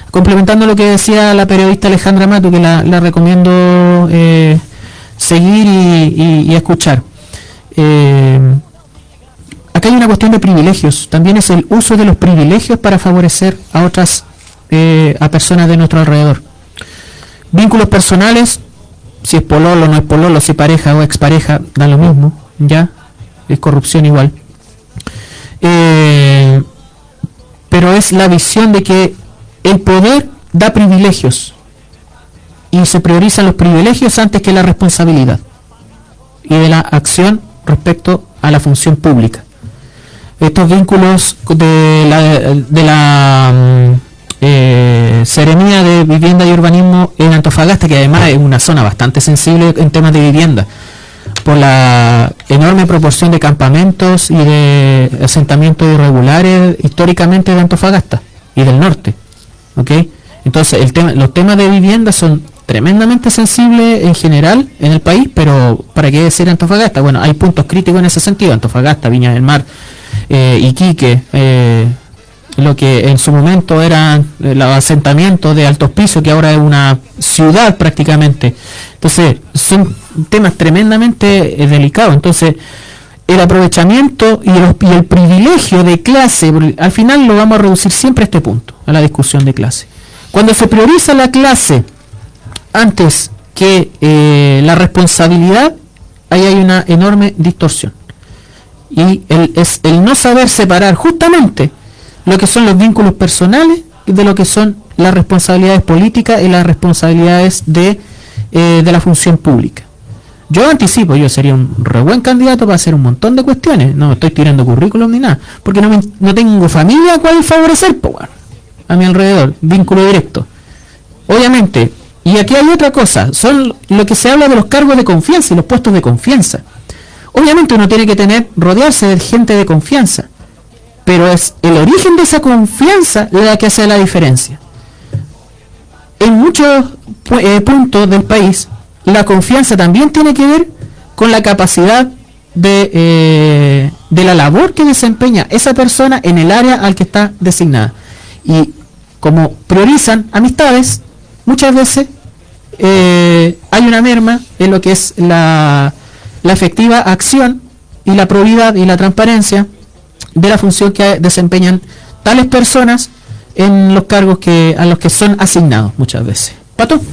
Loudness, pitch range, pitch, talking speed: -6 LUFS, 140-200 Hz, 170 Hz, 150 wpm